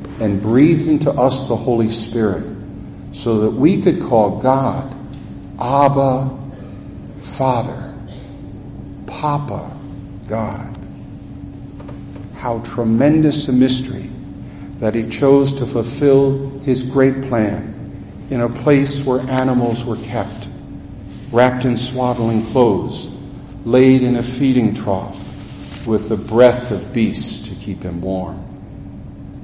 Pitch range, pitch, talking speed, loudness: 110-135 Hz, 125 Hz, 110 wpm, -17 LUFS